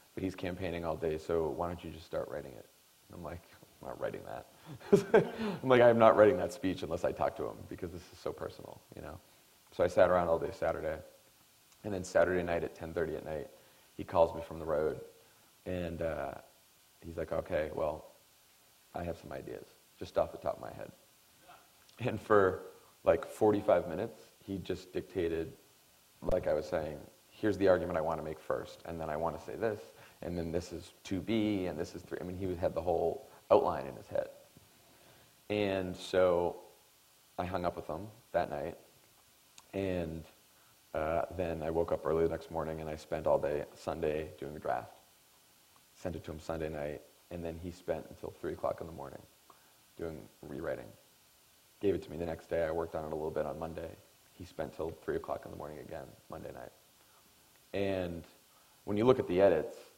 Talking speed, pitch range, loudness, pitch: 200 wpm, 80-100 Hz, -34 LUFS, 90 Hz